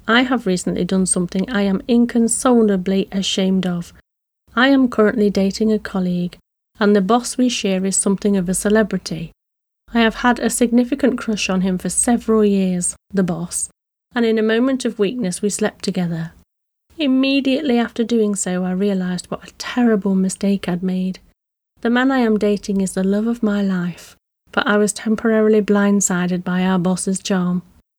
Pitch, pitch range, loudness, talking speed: 205 Hz, 185-230 Hz, -18 LUFS, 170 wpm